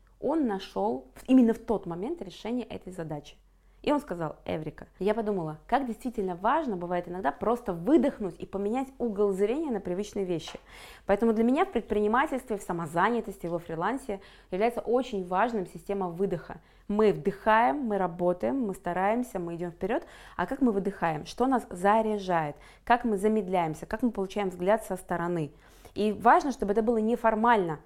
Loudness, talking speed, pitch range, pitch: -29 LUFS, 160 wpm, 180-230 Hz, 205 Hz